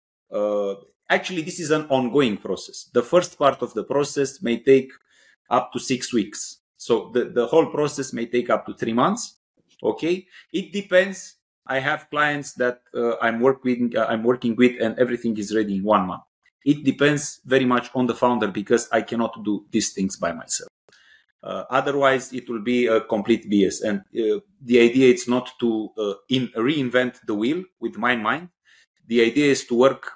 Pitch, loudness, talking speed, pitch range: 125 Hz, -22 LUFS, 185 wpm, 115-140 Hz